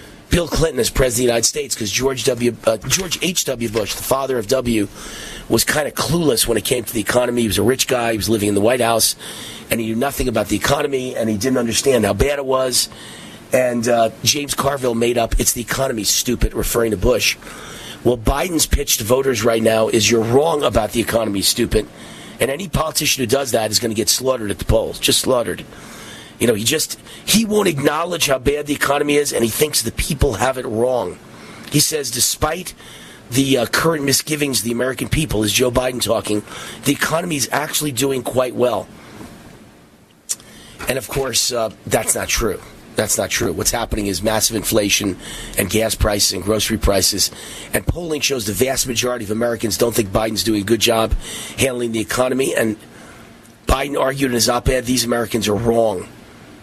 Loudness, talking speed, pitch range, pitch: -18 LUFS, 200 wpm, 110-135 Hz, 120 Hz